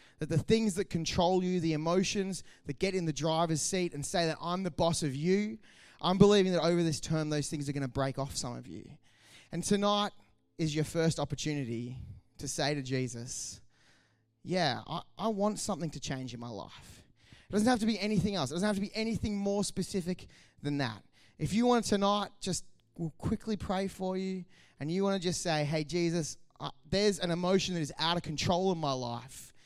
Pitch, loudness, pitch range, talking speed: 170 Hz, -32 LUFS, 145-190 Hz, 210 wpm